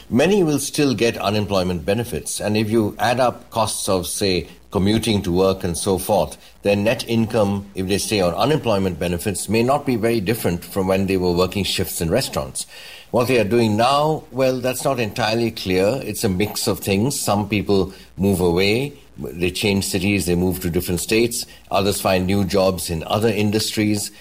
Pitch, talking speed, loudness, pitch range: 100 Hz, 190 wpm, -20 LUFS, 95-115 Hz